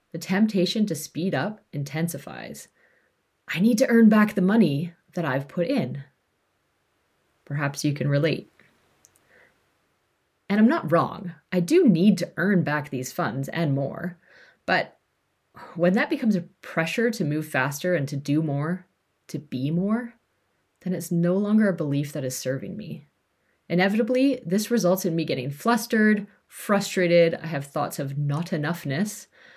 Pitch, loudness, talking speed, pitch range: 175 Hz, -24 LUFS, 150 wpm, 150-205 Hz